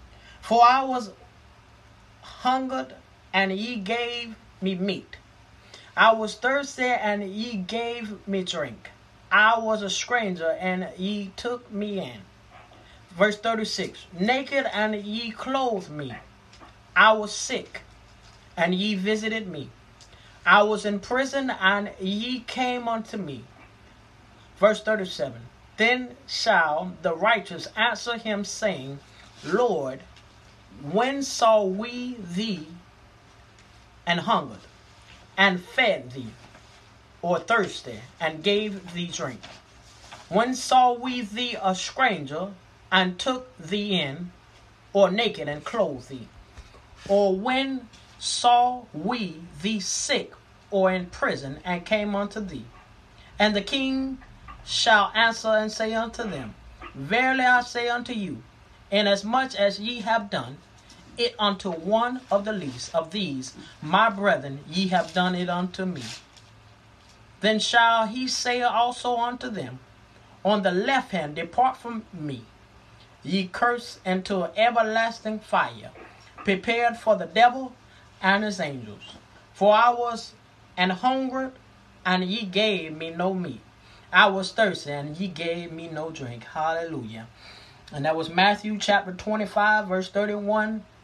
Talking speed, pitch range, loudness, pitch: 125 wpm, 150-230 Hz, -24 LUFS, 200 Hz